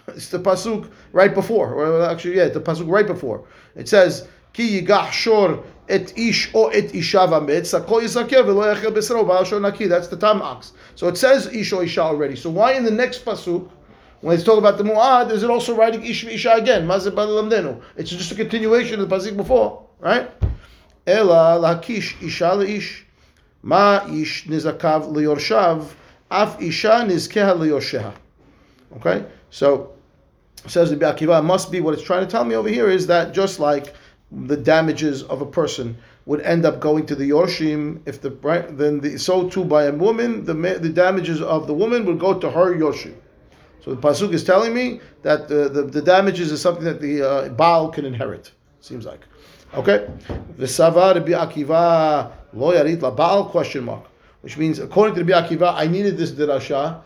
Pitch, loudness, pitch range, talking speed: 175 Hz, -18 LUFS, 155-205 Hz, 185 wpm